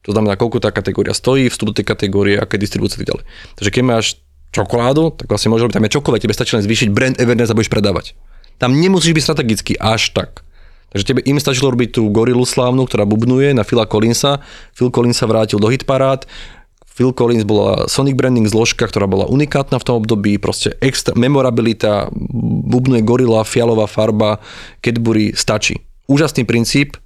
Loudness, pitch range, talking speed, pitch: -14 LUFS, 105-130 Hz, 180 wpm, 115 Hz